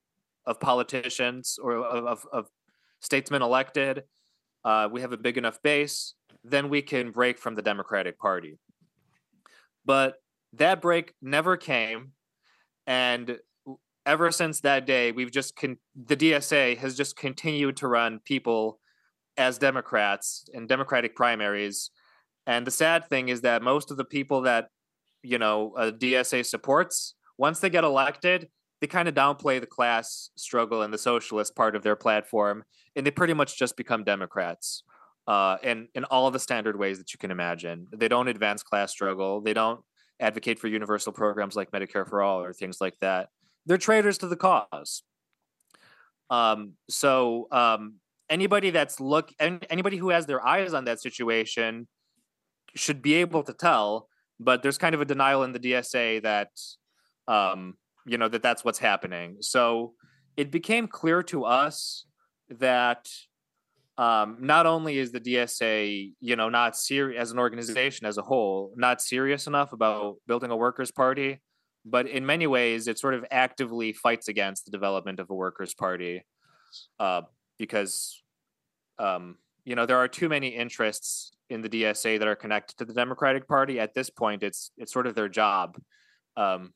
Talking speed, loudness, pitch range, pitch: 165 wpm, -26 LUFS, 110-140 Hz, 125 Hz